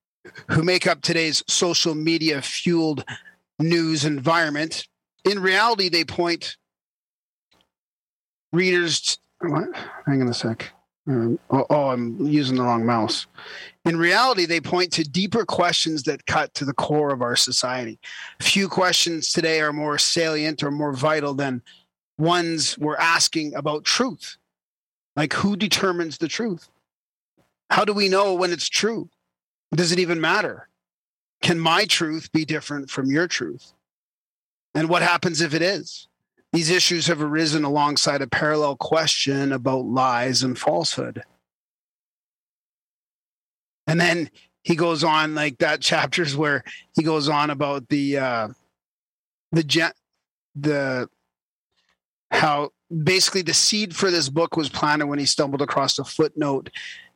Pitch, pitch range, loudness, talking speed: 155 Hz, 135-170 Hz, -21 LUFS, 135 wpm